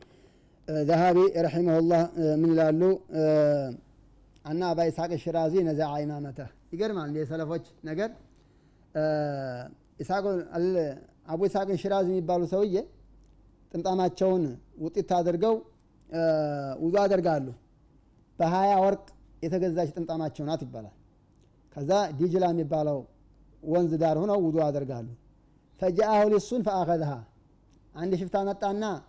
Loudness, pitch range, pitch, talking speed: -27 LUFS, 150-185 Hz, 165 Hz, 85 wpm